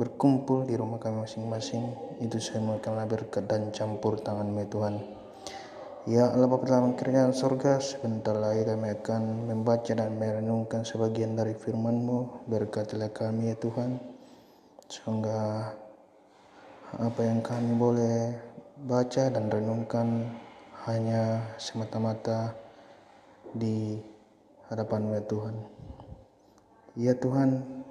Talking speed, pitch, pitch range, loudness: 110 wpm, 115 Hz, 110-120 Hz, -30 LUFS